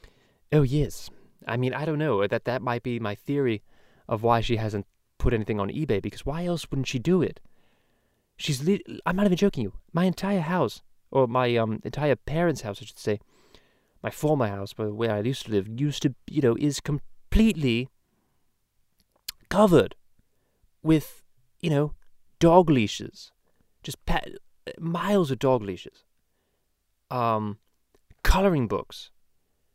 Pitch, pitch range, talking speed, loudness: 125 Hz, 105-150 Hz, 155 wpm, -26 LUFS